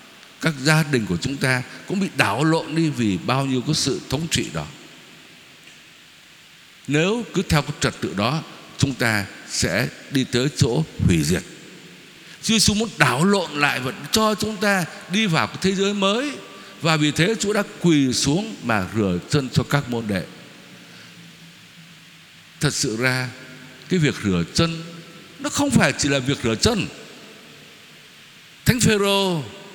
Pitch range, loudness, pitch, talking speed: 130-185 Hz, -21 LUFS, 160 Hz, 165 wpm